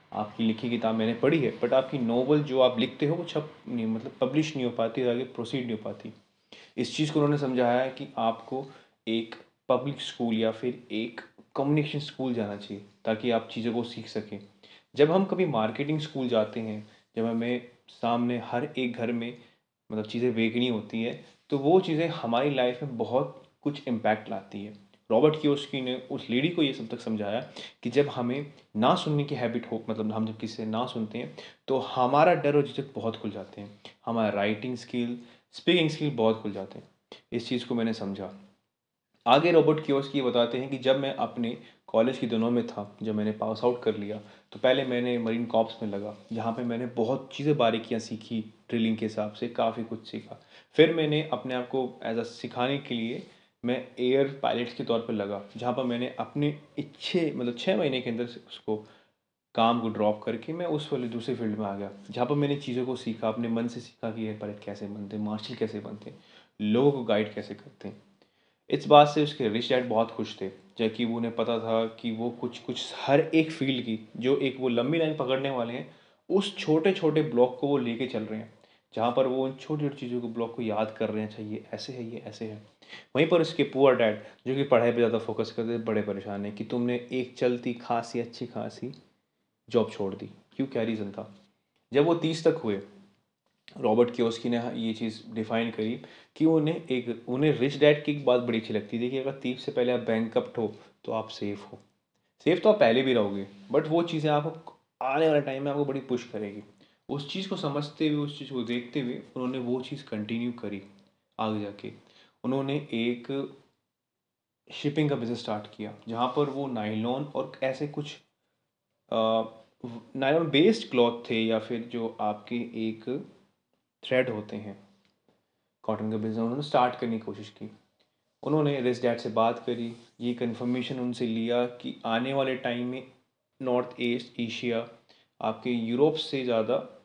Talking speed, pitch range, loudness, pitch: 200 wpm, 110-135 Hz, -29 LUFS, 120 Hz